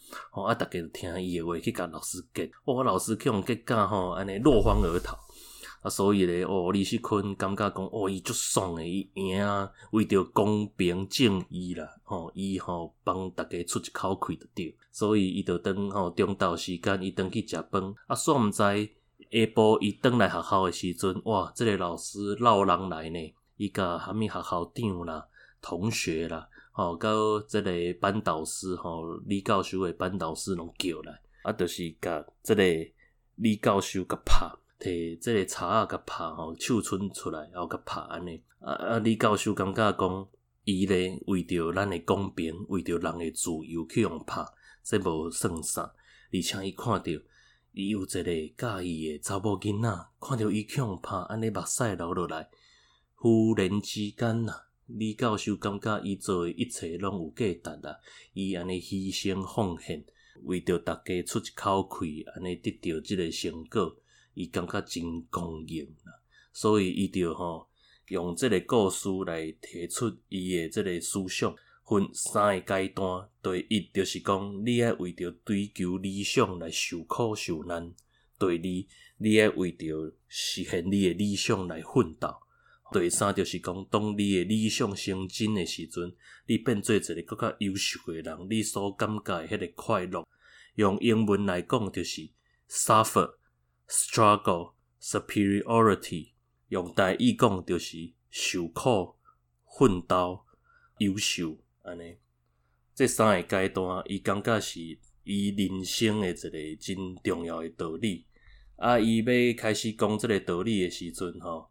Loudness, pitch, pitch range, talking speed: -29 LUFS, 95 Hz, 85-105 Hz, 240 characters per minute